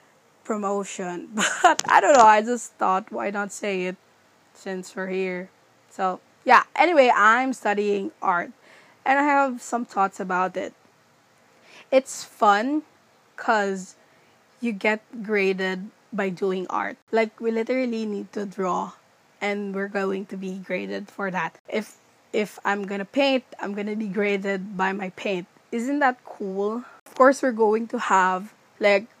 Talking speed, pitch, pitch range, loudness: 155 wpm, 205 Hz, 195-230 Hz, -23 LUFS